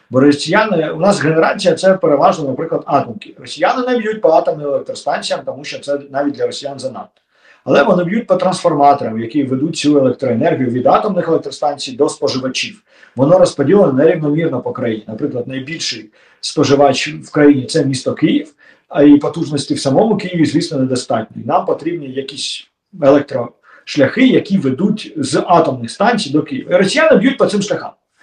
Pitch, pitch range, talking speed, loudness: 155 Hz, 140-195 Hz, 160 wpm, -14 LUFS